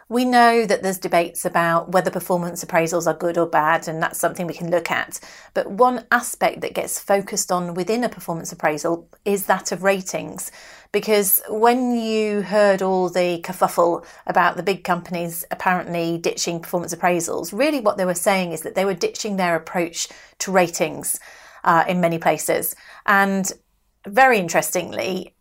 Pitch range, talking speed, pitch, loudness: 170-205 Hz, 170 wpm, 185 Hz, -20 LUFS